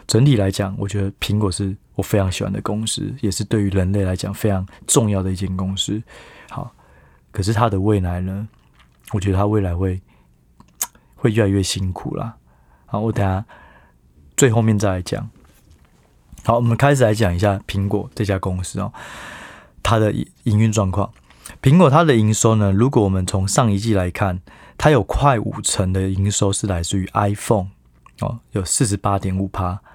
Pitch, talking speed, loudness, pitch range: 100 Hz, 265 characters per minute, -19 LUFS, 95-110 Hz